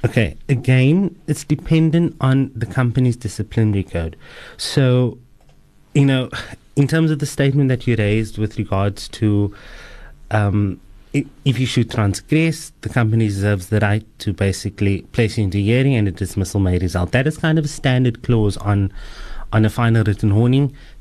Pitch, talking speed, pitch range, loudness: 115 Hz, 165 wpm, 105-135 Hz, -18 LUFS